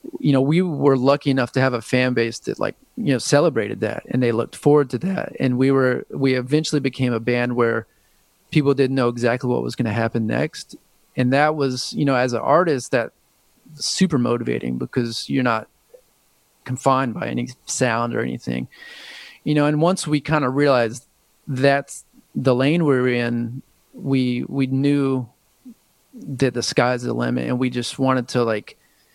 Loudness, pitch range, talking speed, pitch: -20 LUFS, 120-140 Hz, 185 wpm, 130 Hz